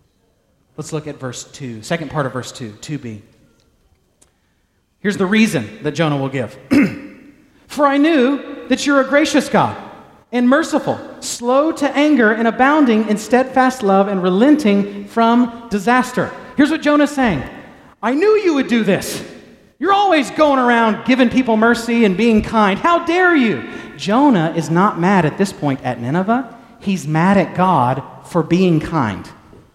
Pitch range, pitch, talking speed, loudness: 160-270 Hz, 220 Hz, 160 wpm, -15 LUFS